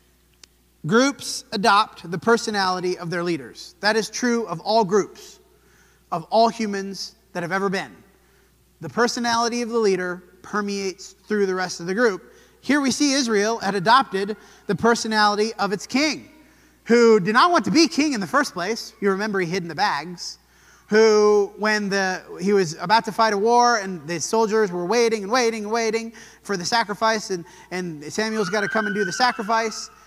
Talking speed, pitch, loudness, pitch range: 185 wpm, 215 Hz, -21 LUFS, 190-230 Hz